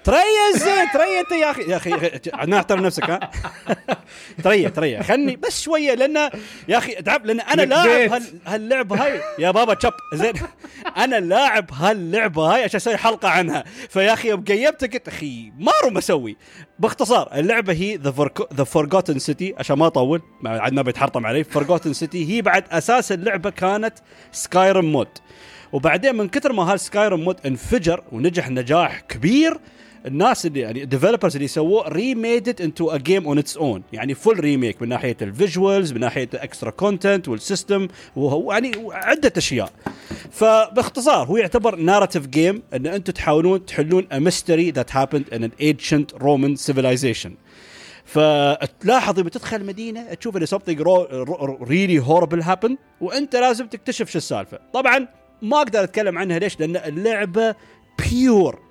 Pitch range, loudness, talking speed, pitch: 150-225 Hz, -19 LUFS, 150 wpm, 185 Hz